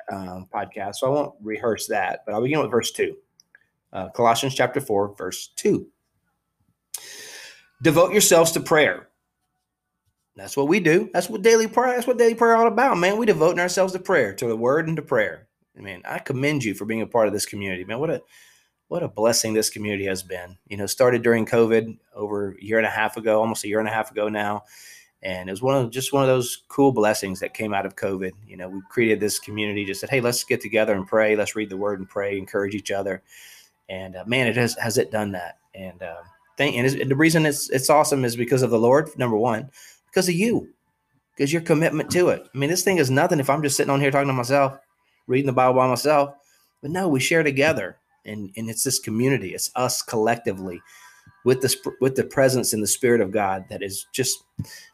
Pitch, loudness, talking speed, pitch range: 120 Hz, -22 LUFS, 230 wpm, 105-145 Hz